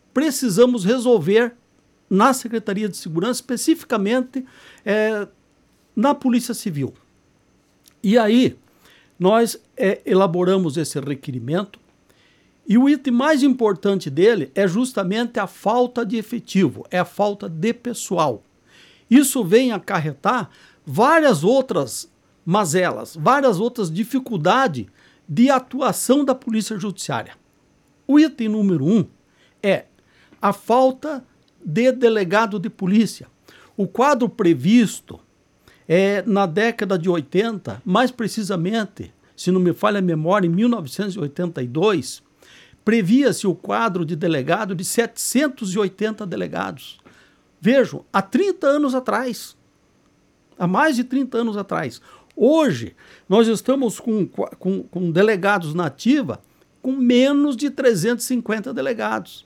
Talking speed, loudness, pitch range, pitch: 110 wpm, -19 LUFS, 185-245 Hz, 215 Hz